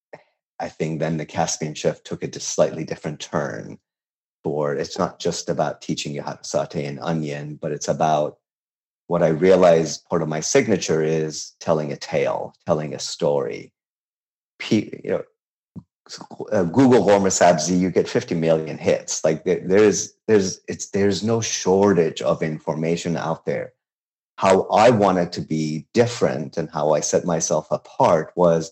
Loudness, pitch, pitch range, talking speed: -21 LUFS, 80 Hz, 80-100 Hz, 160 wpm